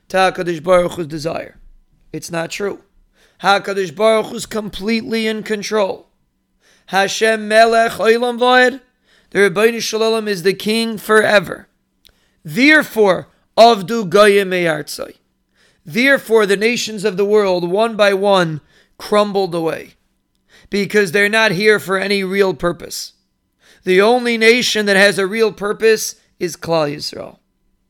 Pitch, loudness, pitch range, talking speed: 210 Hz, -15 LUFS, 190-225 Hz, 120 wpm